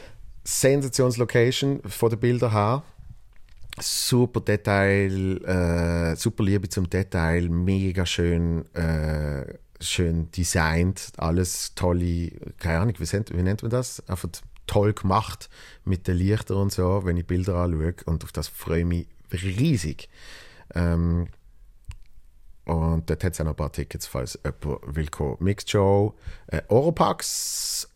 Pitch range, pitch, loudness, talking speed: 85-105 Hz, 90 Hz, -25 LUFS, 135 wpm